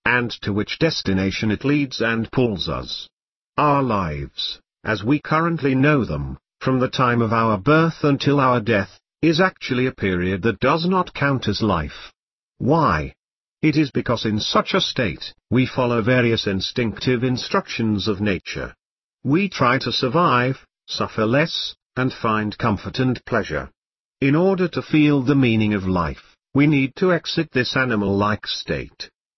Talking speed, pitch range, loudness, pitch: 155 wpm, 105-145 Hz, -20 LUFS, 125 Hz